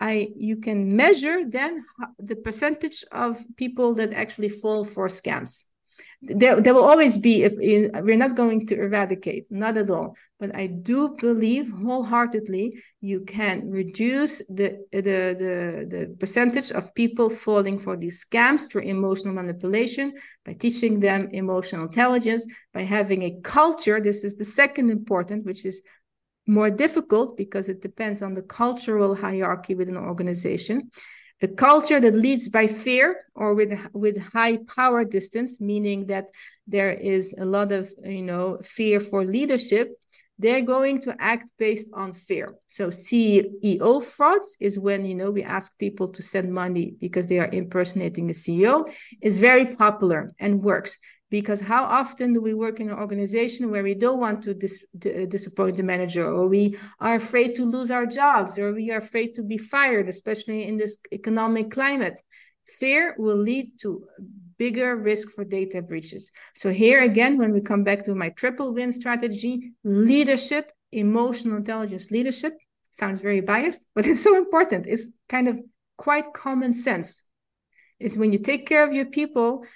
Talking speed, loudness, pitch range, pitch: 165 wpm, -23 LUFS, 195-245 Hz, 215 Hz